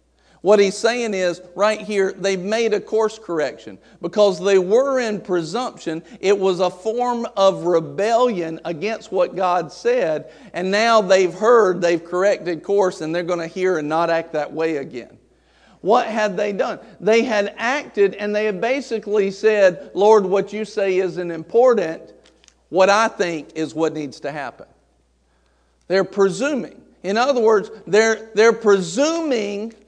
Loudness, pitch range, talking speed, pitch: -19 LUFS, 175-220 Hz, 155 wpm, 200 Hz